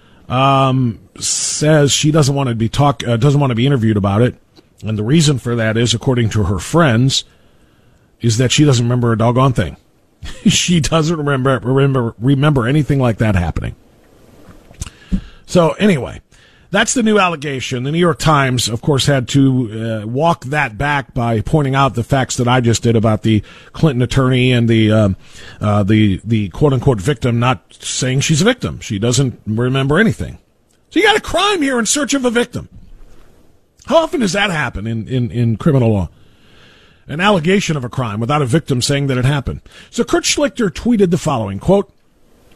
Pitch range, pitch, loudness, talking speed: 115-155 Hz, 130 Hz, -15 LUFS, 185 wpm